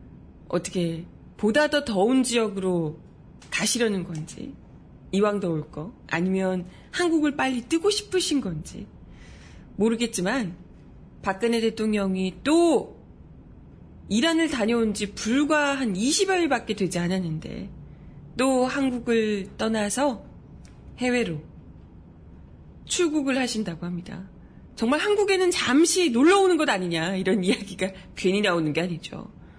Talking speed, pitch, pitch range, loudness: 245 characters per minute, 215 Hz, 180-275 Hz, -24 LUFS